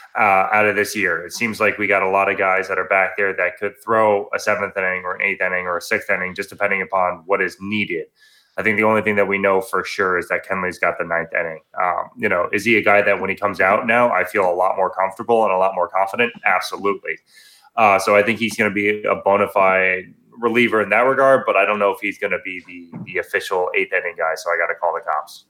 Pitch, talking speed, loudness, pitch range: 100 Hz, 275 wpm, -18 LUFS, 95-110 Hz